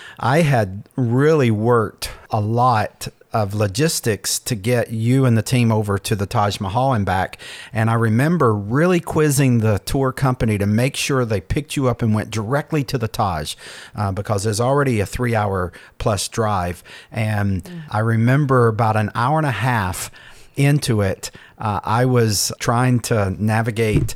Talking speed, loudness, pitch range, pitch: 170 wpm, -19 LUFS, 105-130 Hz, 115 Hz